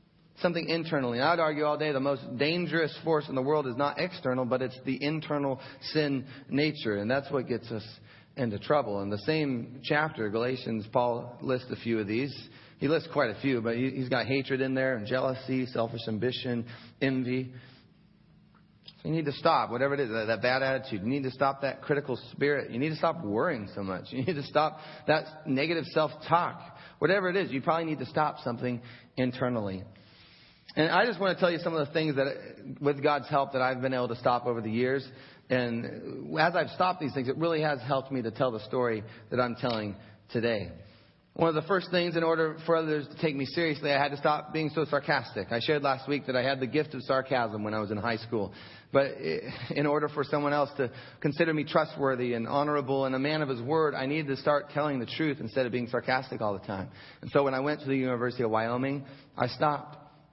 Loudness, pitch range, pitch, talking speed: -30 LUFS, 125-150 Hz, 135 Hz, 225 wpm